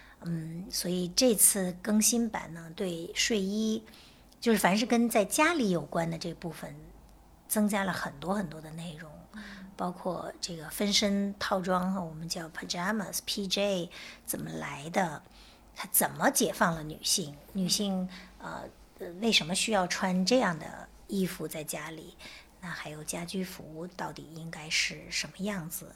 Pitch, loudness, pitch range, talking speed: 185 Hz, -30 LUFS, 165-205 Hz, 230 characters per minute